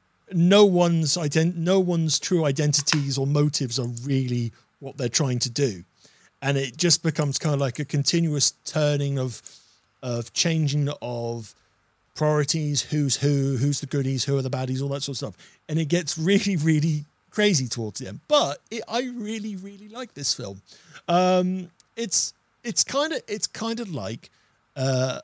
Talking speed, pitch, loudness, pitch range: 170 wpm, 145 Hz, -24 LUFS, 130-175 Hz